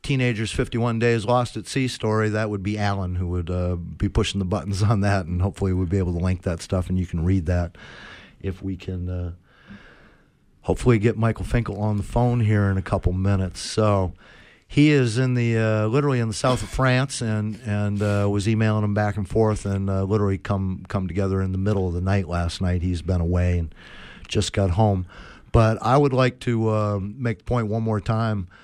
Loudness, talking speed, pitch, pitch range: -23 LUFS, 220 wpm, 105 Hz, 95-110 Hz